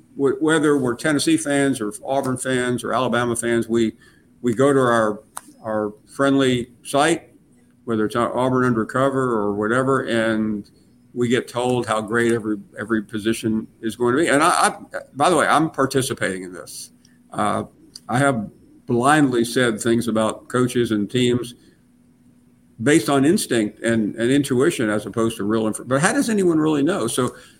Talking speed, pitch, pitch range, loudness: 165 wpm, 120 Hz, 110-135 Hz, -20 LUFS